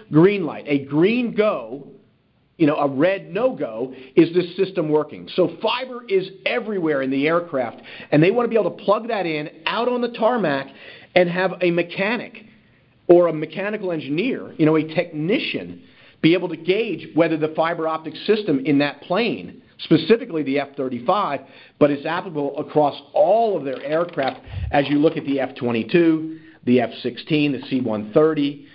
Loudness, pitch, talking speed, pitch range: -21 LUFS, 160 Hz, 175 wpm, 145-190 Hz